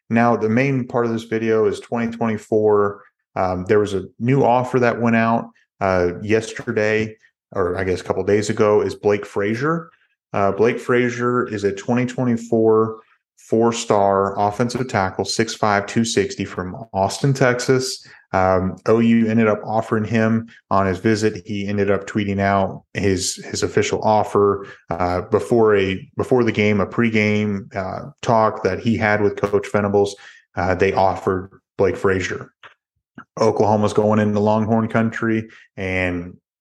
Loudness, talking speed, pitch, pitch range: -19 LUFS, 150 wpm, 110 Hz, 100-115 Hz